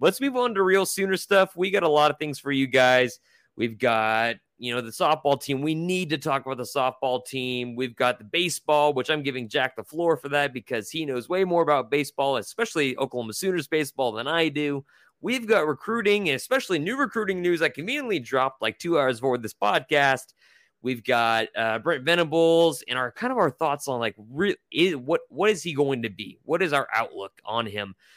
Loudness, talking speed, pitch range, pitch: -24 LUFS, 215 wpm, 125-170 Hz, 145 Hz